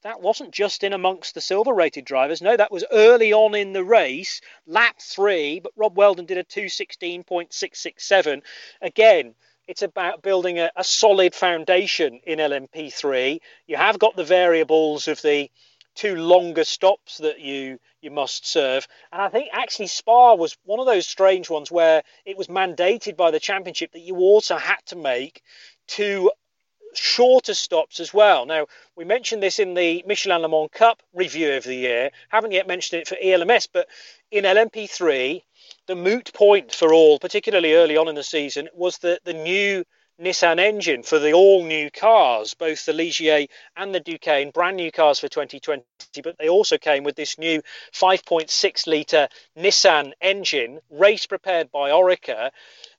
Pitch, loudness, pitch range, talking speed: 185 Hz, -19 LUFS, 160-210 Hz, 170 wpm